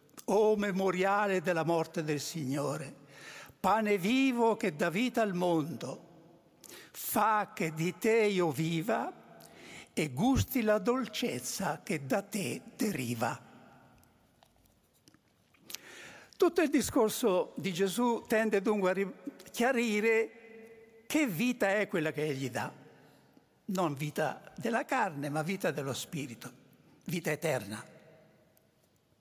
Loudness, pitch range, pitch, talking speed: -32 LUFS, 170-225 Hz, 200 Hz, 110 wpm